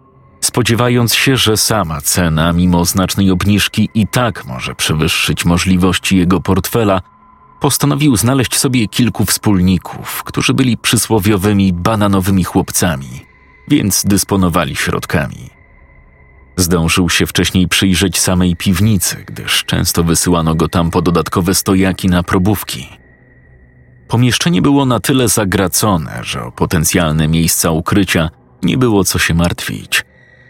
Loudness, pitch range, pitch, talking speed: -13 LUFS, 85-110 Hz, 95 Hz, 115 wpm